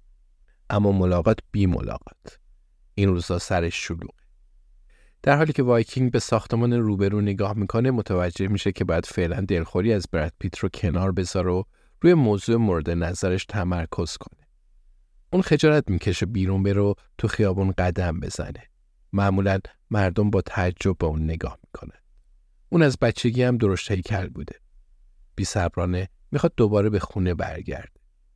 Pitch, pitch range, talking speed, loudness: 95 Hz, 90-110 Hz, 140 wpm, -23 LUFS